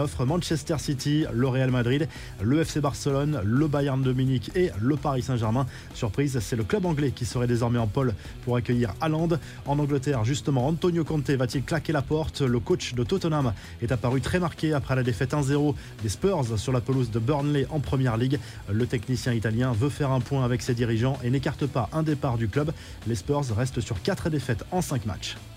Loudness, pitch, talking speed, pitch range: -26 LUFS, 130 Hz, 200 wpm, 120-145 Hz